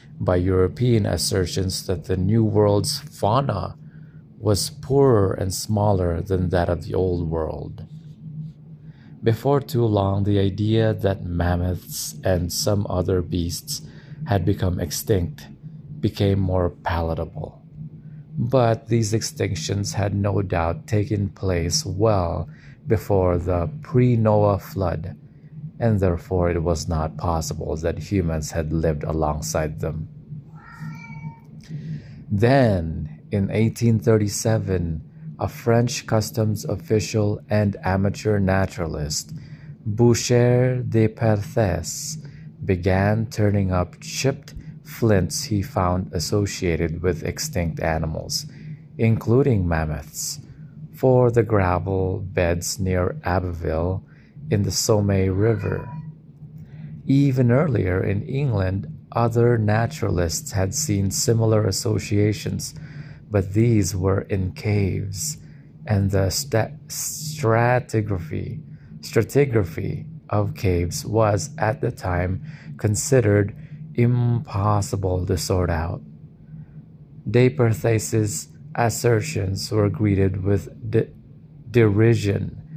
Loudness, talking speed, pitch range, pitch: -22 LUFS, 100 wpm, 95-140 Hz, 110 Hz